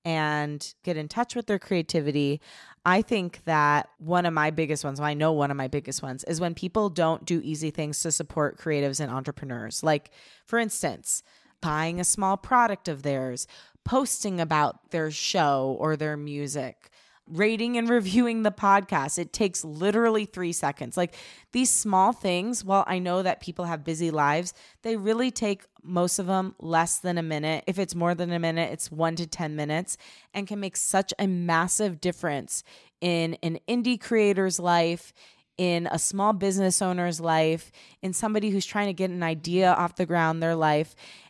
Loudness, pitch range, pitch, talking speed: -26 LUFS, 155-195 Hz, 175 Hz, 185 wpm